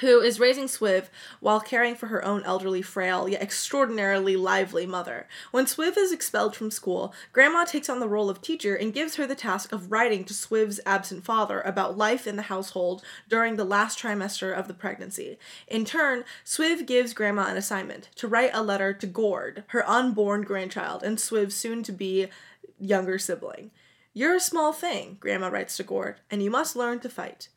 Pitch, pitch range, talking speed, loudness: 215 Hz, 195-245 Hz, 190 wpm, -26 LUFS